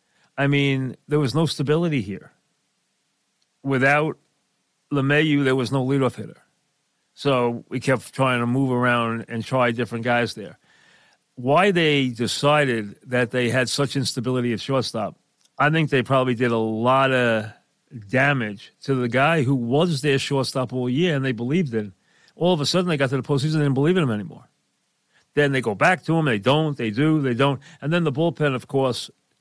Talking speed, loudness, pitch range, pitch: 185 wpm, -21 LUFS, 125-145 Hz, 135 Hz